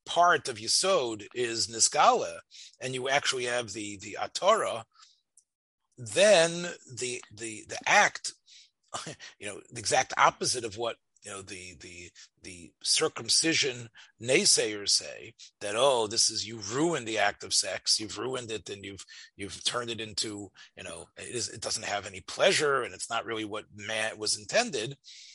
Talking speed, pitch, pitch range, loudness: 160 wpm, 110 Hz, 105-125 Hz, -27 LUFS